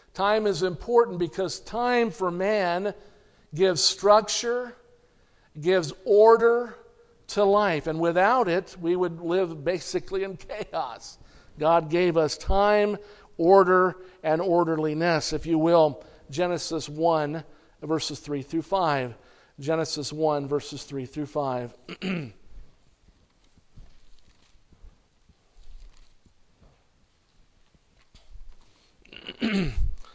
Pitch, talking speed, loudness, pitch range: 170 Hz, 90 wpm, -24 LUFS, 145-195 Hz